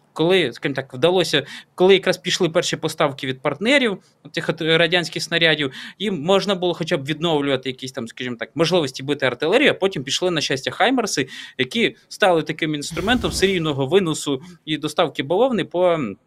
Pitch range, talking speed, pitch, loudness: 145-180 Hz, 160 wpm, 165 Hz, -20 LUFS